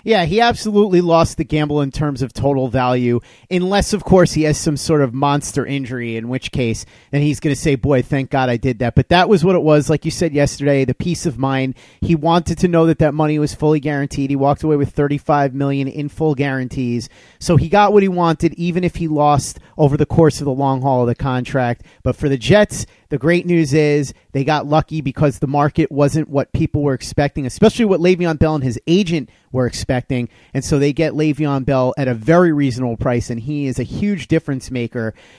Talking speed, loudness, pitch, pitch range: 225 wpm, -17 LUFS, 145 Hz, 130-160 Hz